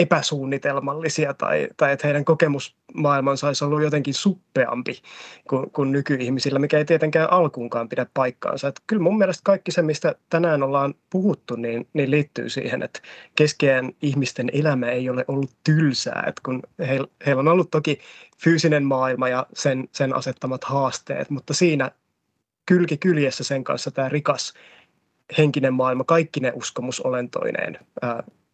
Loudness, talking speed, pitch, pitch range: -22 LUFS, 145 wpm, 140 Hz, 130-155 Hz